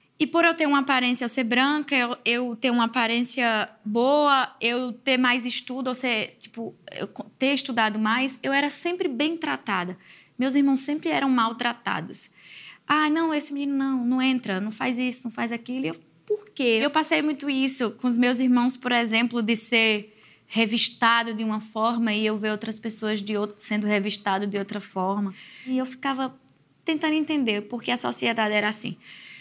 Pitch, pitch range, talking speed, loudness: 245 Hz, 220-270 Hz, 180 wpm, -24 LUFS